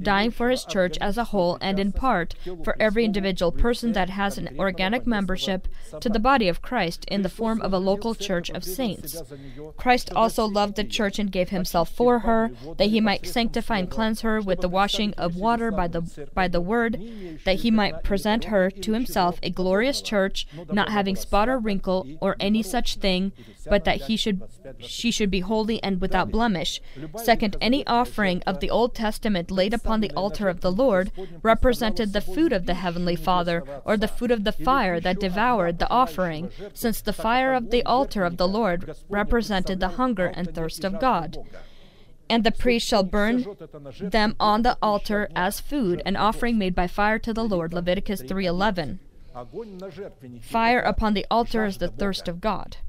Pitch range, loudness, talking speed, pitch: 180-225 Hz, -24 LUFS, 190 wpm, 200 Hz